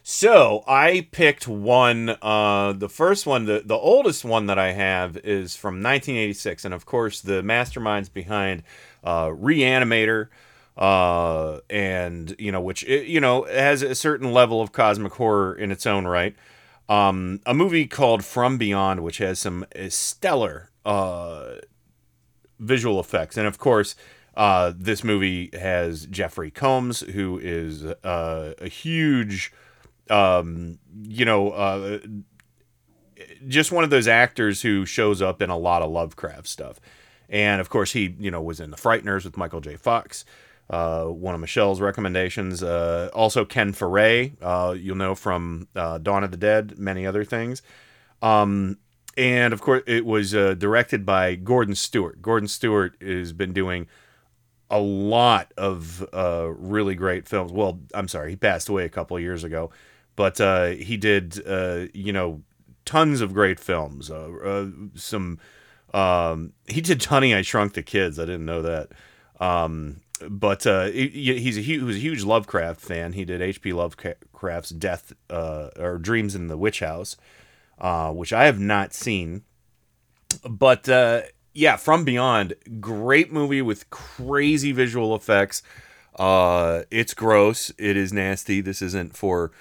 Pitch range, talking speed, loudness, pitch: 90-115 Hz, 155 wpm, -22 LUFS, 100 Hz